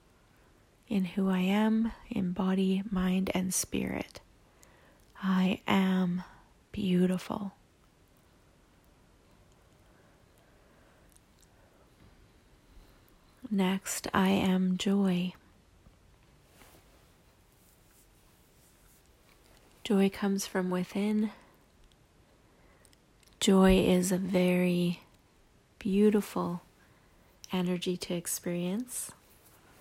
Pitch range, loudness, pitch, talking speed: 180-200 Hz, -30 LUFS, 190 Hz, 55 wpm